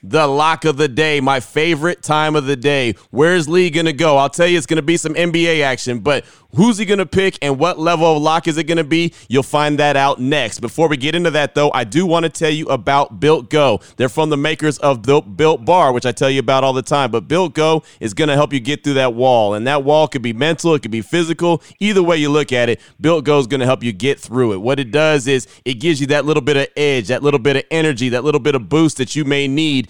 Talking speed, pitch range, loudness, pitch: 270 wpm, 135-160 Hz, -15 LUFS, 150 Hz